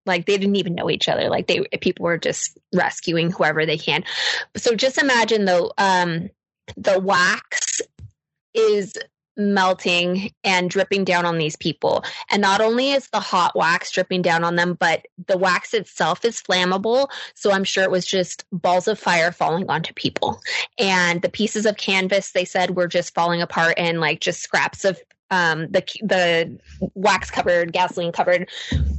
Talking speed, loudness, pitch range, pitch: 175 wpm, -20 LUFS, 175-210 Hz, 185 Hz